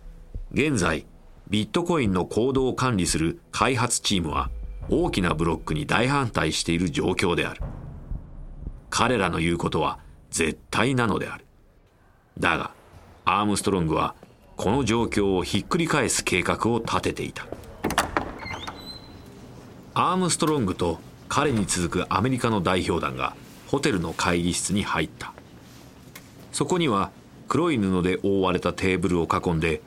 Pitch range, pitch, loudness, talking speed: 85-110 Hz, 90 Hz, -24 LUFS, 280 characters per minute